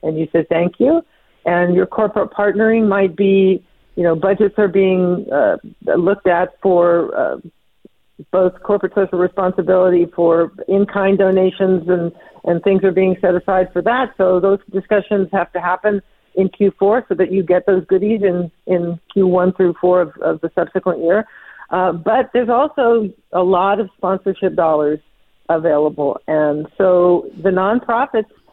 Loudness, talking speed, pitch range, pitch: -16 LUFS, 160 wpm, 180-200 Hz, 190 Hz